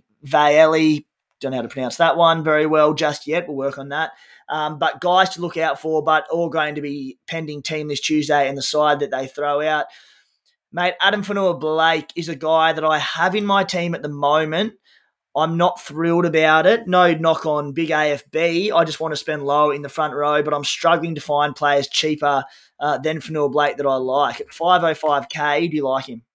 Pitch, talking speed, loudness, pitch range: 155 Hz, 215 wpm, -19 LUFS, 145-165 Hz